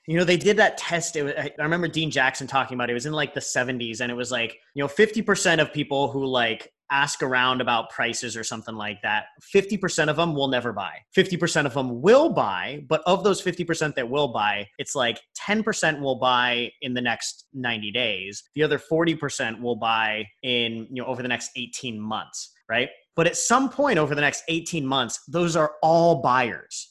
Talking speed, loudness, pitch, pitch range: 210 wpm, -24 LUFS, 140 Hz, 120-165 Hz